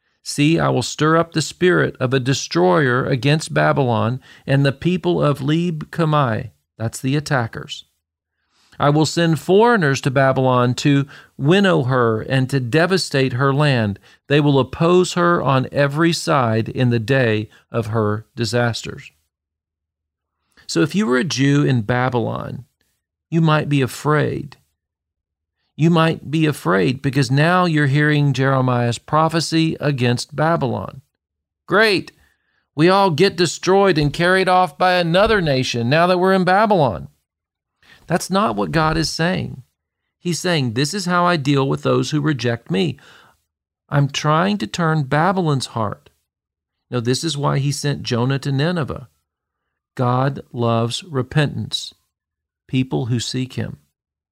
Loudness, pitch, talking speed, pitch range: -18 LUFS, 140 Hz, 140 wpm, 120-160 Hz